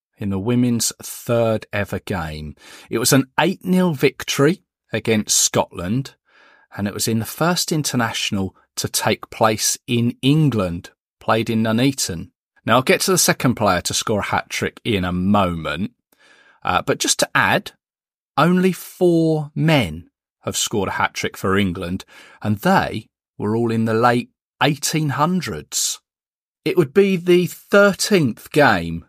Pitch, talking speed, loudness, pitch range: 120 Hz, 145 wpm, -19 LUFS, 105-155 Hz